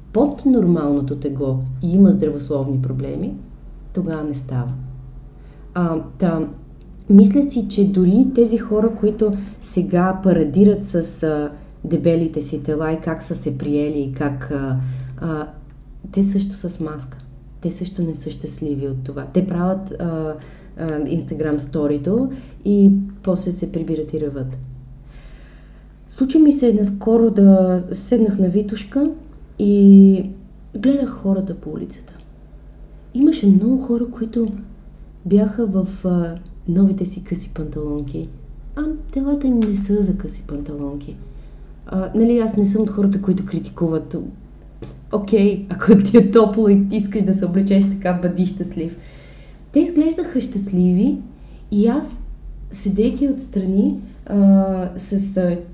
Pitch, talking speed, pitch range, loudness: 185 Hz, 130 wpm, 155-205 Hz, -18 LUFS